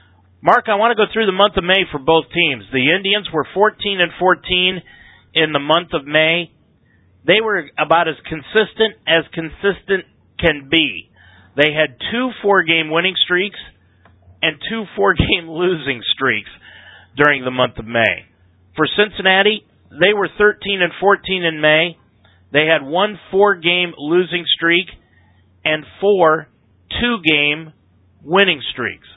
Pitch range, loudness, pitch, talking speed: 135-190 Hz, -16 LUFS, 165 Hz, 140 wpm